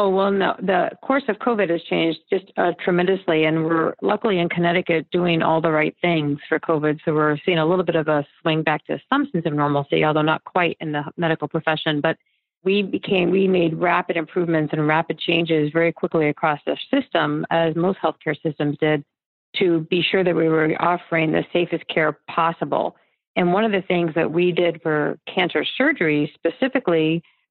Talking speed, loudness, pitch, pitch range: 195 wpm, -21 LUFS, 165 Hz, 155-180 Hz